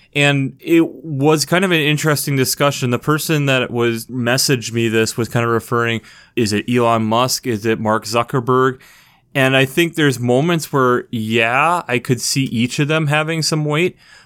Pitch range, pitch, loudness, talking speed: 120-150 Hz, 130 Hz, -16 LUFS, 180 wpm